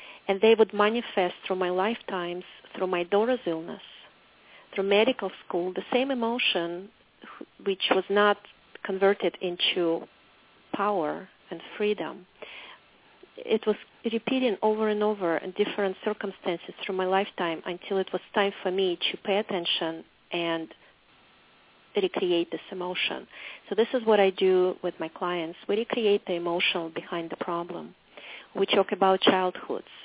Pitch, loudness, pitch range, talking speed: 195 Hz, -27 LUFS, 180-210 Hz, 140 wpm